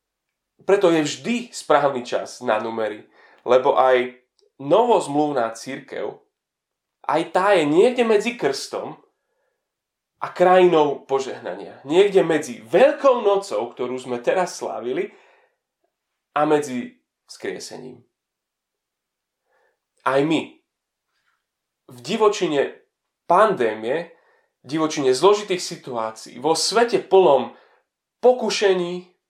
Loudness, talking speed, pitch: -20 LUFS, 90 wpm, 190 Hz